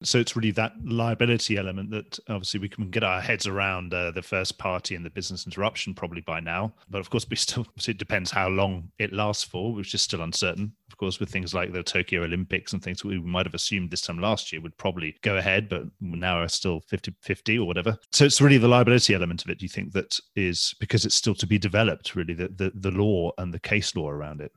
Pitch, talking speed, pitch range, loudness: 100 Hz, 250 wpm, 90-110 Hz, -26 LUFS